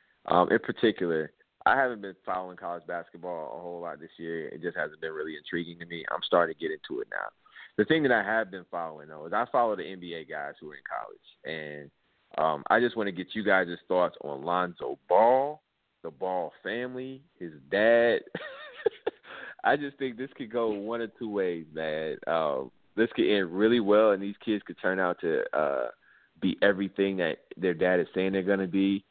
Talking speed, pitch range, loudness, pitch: 205 wpm, 85-120 Hz, -29 LUFS, 100 Hz